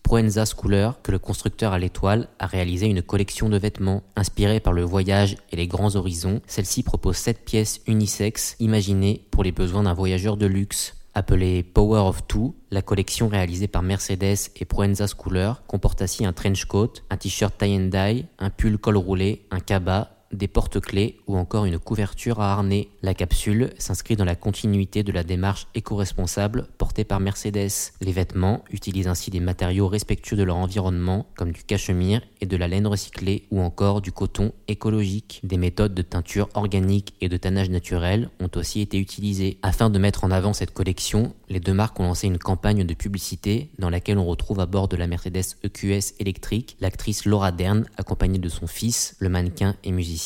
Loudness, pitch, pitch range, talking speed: -24 LUFS, 100 Hz, 95-105 Hz, 185 wpm